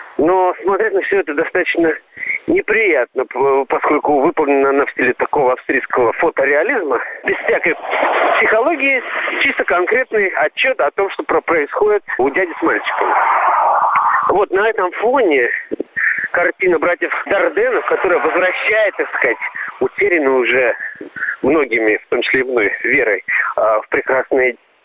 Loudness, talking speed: -15 LUFS, 125 wpm